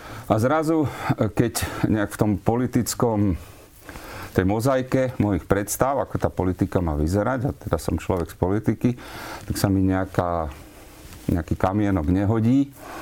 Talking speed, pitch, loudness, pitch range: 135 wpm, 105 Hz, -23 LUFS, 95-120 Hz